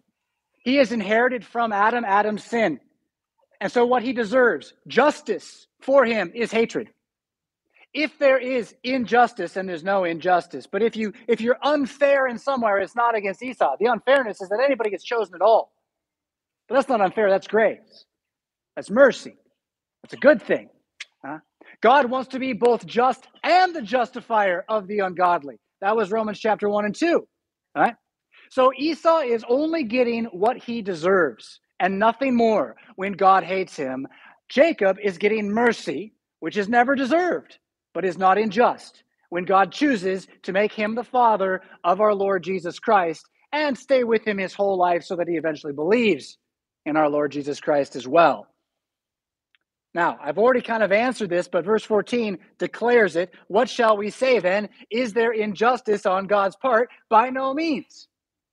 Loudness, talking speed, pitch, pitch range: -22 LUFS, 165 wpm, 225 Hz, 195-255 Hz